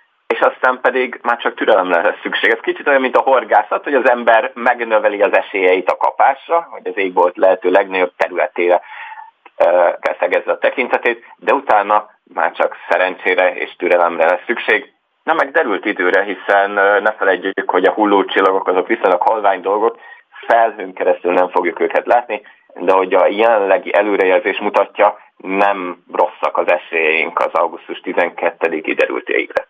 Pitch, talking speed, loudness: 380 Hz, 150 wpm, -15 LUFS